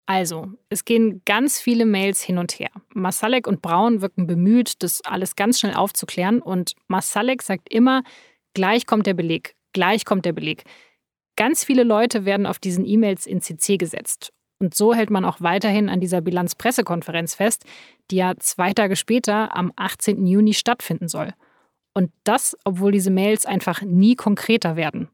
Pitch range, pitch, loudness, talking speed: 185-225 Hz, 200 Hz, -20 LUFS, 165 wpm